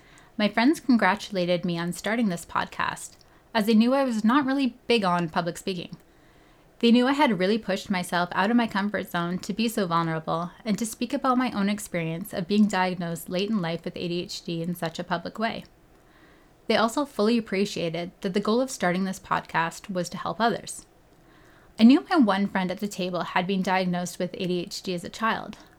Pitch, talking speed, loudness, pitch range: 190 Hz, 200 wpm, -25 LUFS, 175-225 Hz